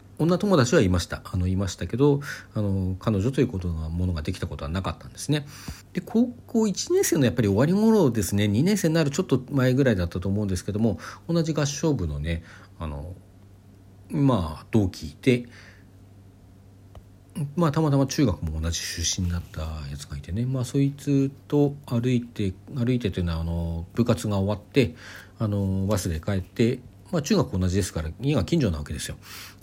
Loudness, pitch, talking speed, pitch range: -25 LUFS, 100 Hz, 300 characters per minute, 95-135 Hz